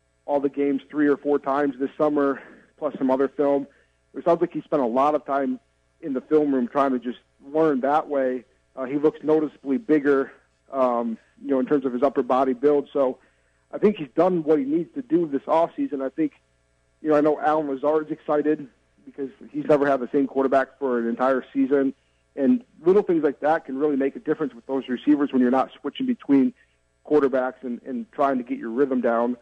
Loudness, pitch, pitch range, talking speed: -23 LUFS, 140 Hz, 130-150 Hz, 220 wpm